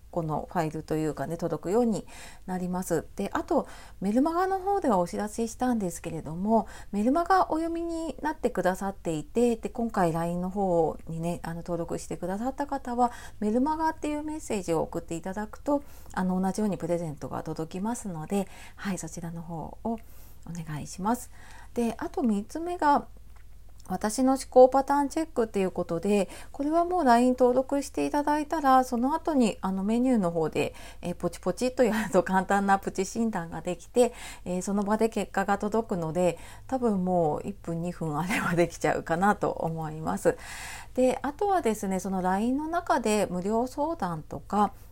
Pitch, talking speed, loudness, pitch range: 205 Hz, 370 characters per minute, -28 LUFS, 175-255 Hz